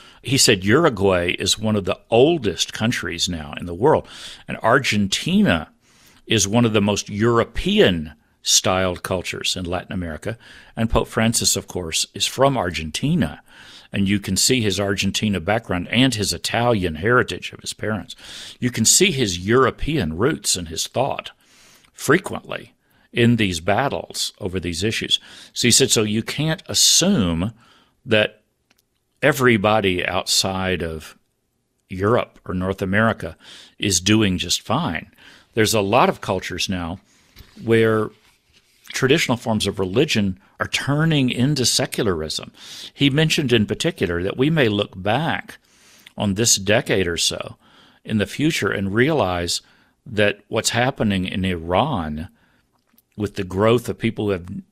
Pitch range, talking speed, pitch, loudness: 95-120 Hz, 140 wpm, 105 Hz, -19 LUFS